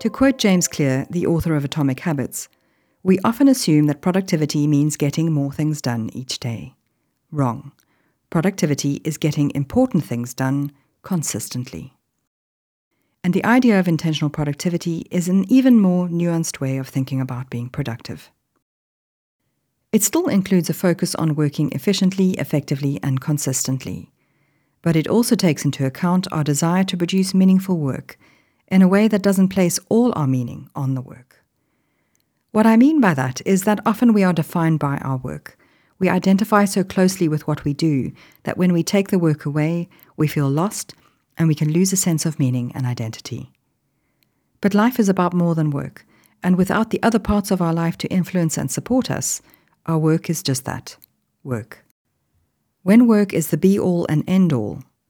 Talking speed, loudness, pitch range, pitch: 170 wpm, -19 LUFS, 140-190 Hz, 165 Hz